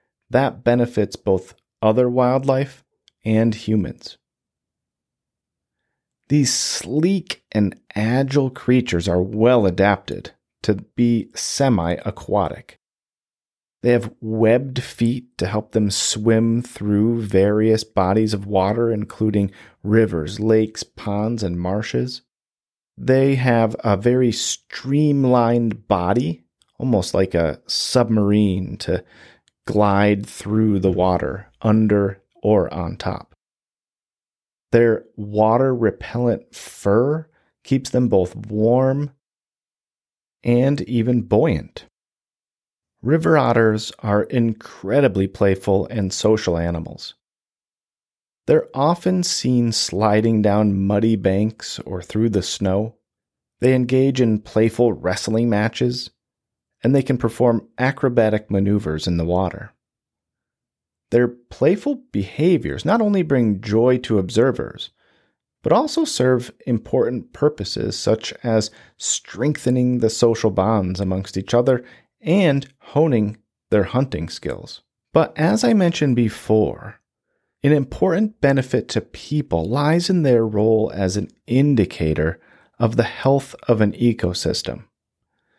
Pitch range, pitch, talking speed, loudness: 100-125 Hz, 115 Hz, 105 wpm, -19 LUFS